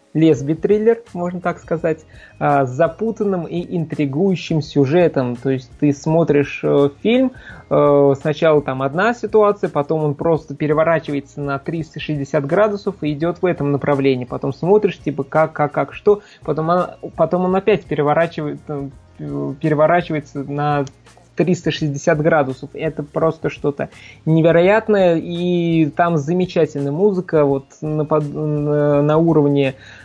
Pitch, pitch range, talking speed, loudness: 155 Hz, 145-175 Hz, 120 wpm, -18 LUFS